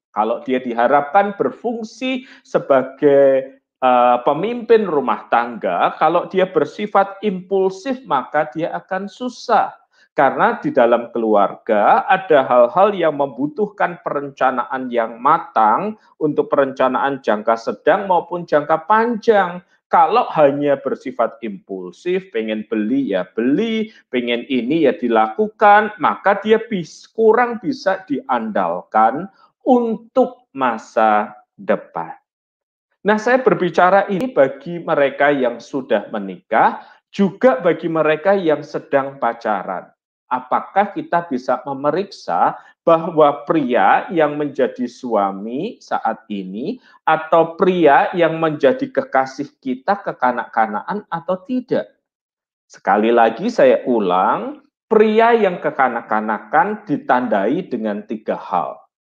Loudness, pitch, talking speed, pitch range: -17 LUFS, 165 Hz, 105 wpm, 130-210 Hz